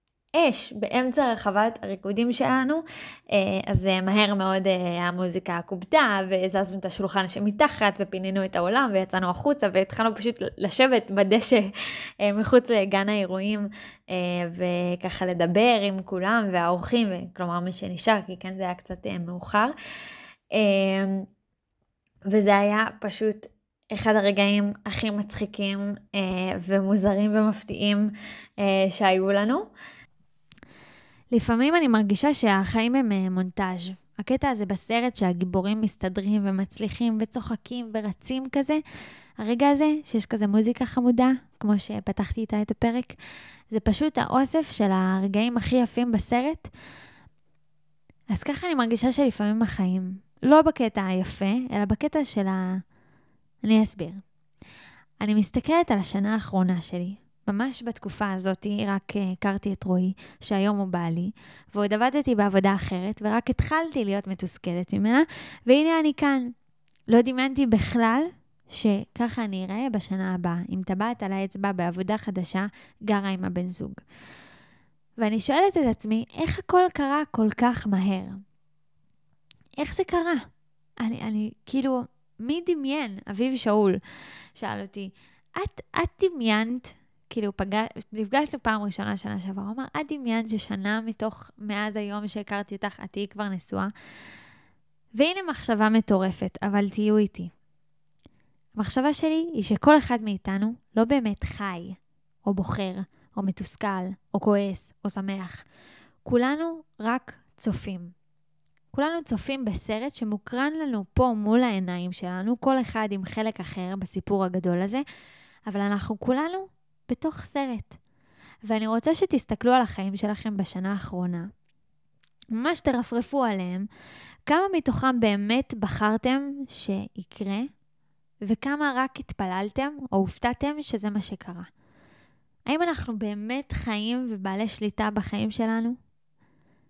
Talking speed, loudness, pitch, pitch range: 120 wpm, -26 LUFS, 210 Hz, 190-240 Hz